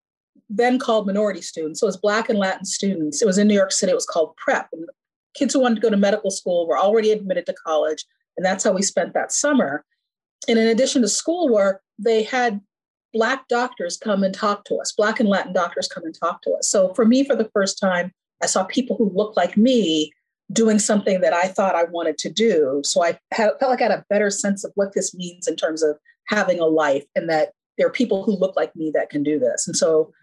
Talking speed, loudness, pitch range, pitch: 245 wpm, -20 LUFS, 180-240 Hz, 205 Hz